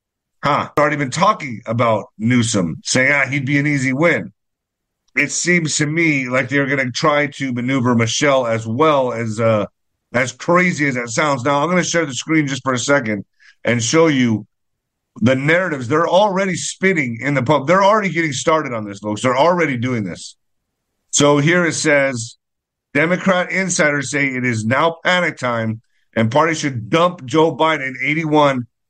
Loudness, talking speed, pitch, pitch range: -16 LUFS, 180 wpm, 140 Hz, 120-160 Hz